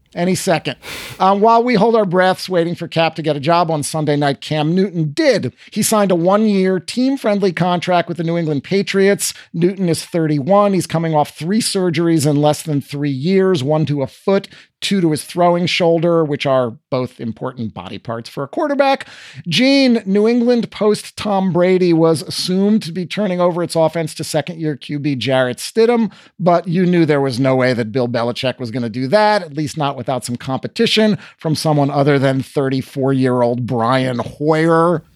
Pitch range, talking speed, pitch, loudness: 140-190 Hz, 195 wpm, 165 Hz, -16 LUFS